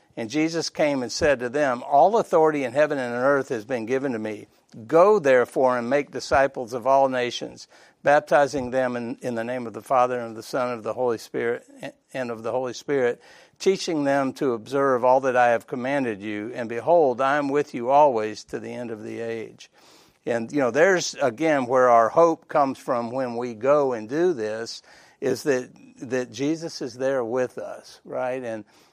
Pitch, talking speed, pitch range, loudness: 130 Hz, 205 wpm, 120-145 Hz, -23 LUFS